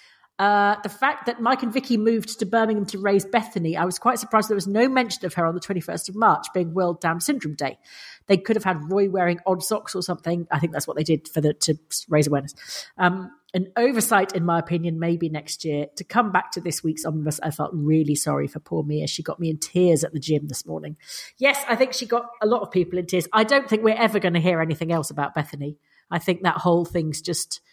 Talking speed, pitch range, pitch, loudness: 250 wpm, 160-210 Hz, 180 Hz, -23 LUFS